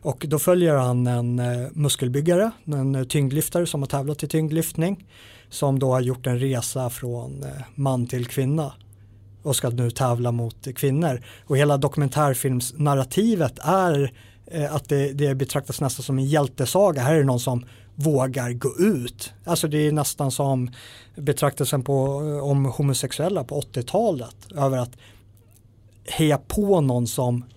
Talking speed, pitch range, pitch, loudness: 140 wpm, 125-150 Hz, 135 Hz, -23 LUFS